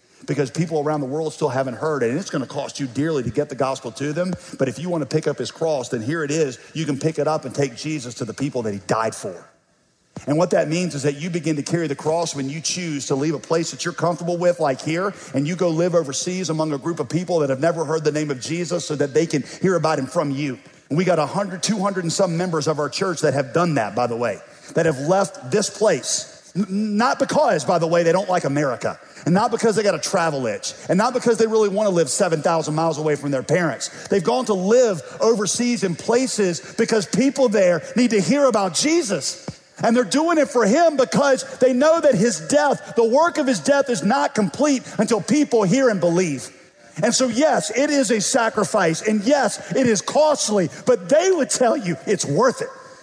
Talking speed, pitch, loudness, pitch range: 245 wpm, 175 Hz, -20 LUFS, 150-220 Hz